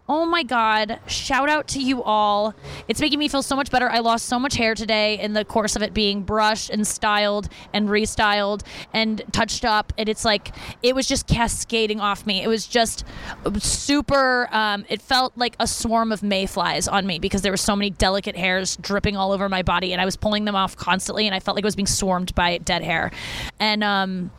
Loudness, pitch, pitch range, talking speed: -21 LUFS, 210 Hz, 200-230 Hz, 220 wpm